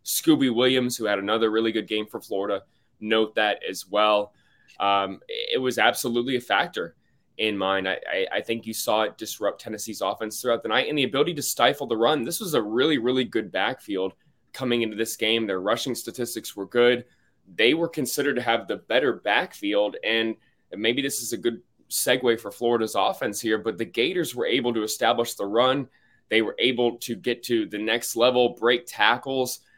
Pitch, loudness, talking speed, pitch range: 115 Hz, -24 LUFS, 195 wpm, 110-125 Hz